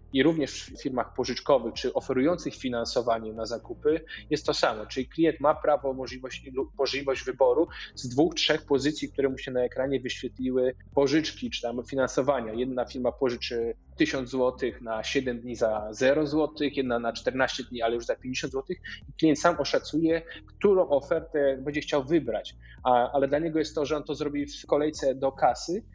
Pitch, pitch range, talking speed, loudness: 135 Hz, 125-150 Hz, 175 wpm, -28 LUFS